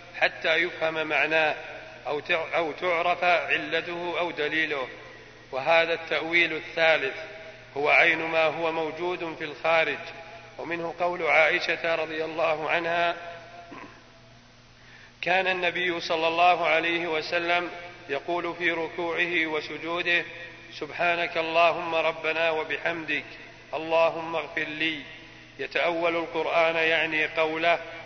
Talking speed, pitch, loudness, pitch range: 100 wpm, 165 Hz, -25 LUFS, 160-170 Hz